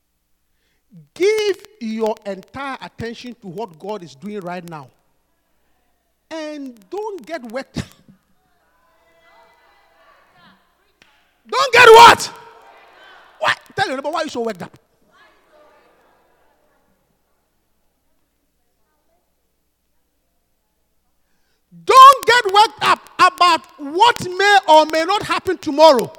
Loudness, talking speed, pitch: -13 LUFS, 90 wpm, 295 Hz